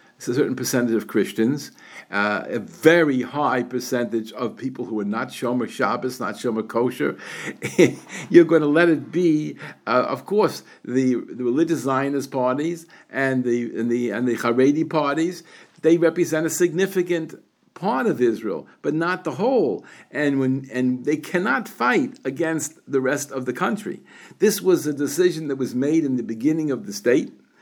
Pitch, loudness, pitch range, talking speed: 140 Hz, -22 LUFS, 125-165 Hz, 170 wpm